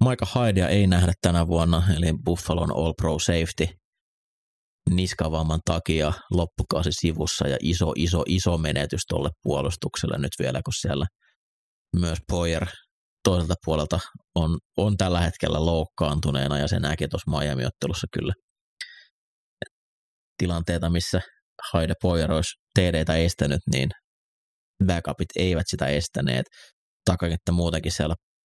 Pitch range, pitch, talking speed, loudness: 80-90 Hz, 85 Hz, 120 wpm, -25 LUFS